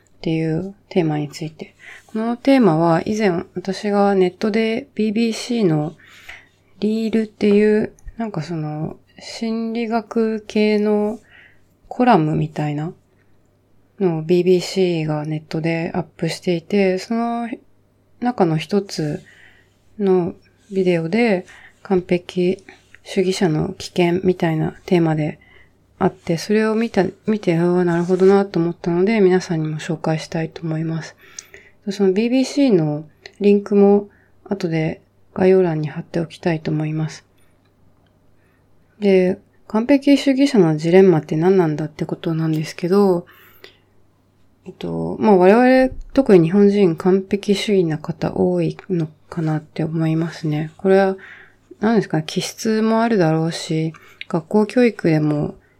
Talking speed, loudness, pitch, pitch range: 260 characters per minute, -18 LUFS, 180 Hz, 160-205 Hz